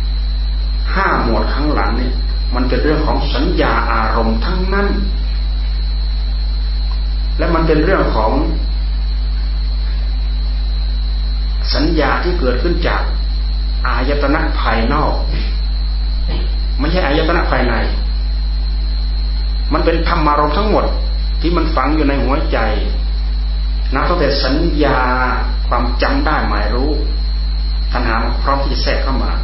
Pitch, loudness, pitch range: 75 Hz, -17 LUFS, 70-120 Hz